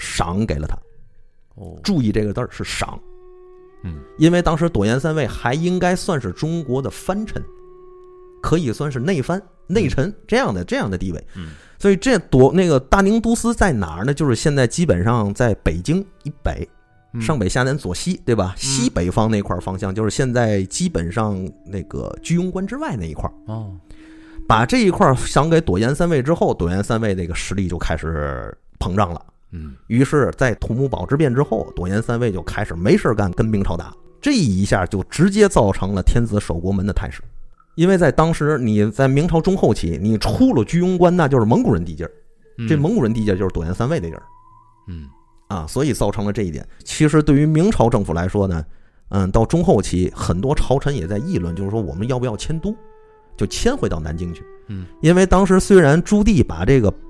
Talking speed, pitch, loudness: 295 characters per minute, 120 Hz, -18 LUFS